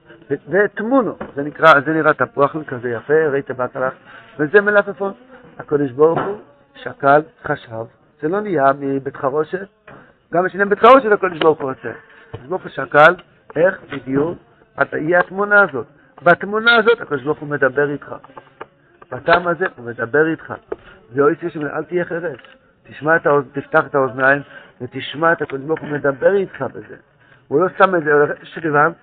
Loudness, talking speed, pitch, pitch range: -17 LUFS, 155 wpm, 155 Hz, 140-180 Hz